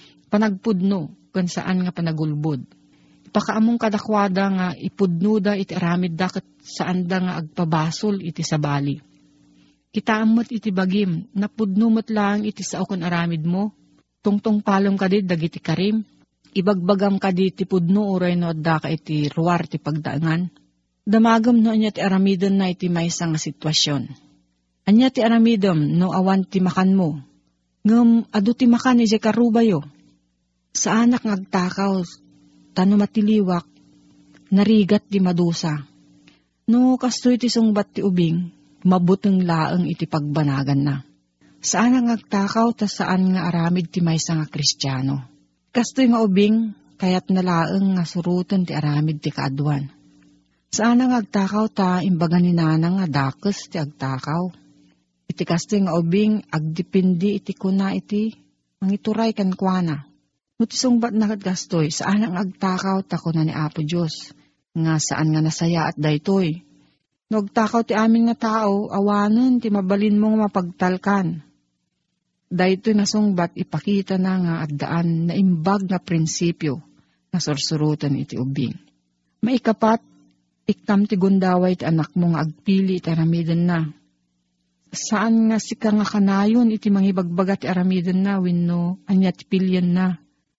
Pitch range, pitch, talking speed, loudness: 160-205 Hz, 185 Hz, 130 wpm, -20 LUFS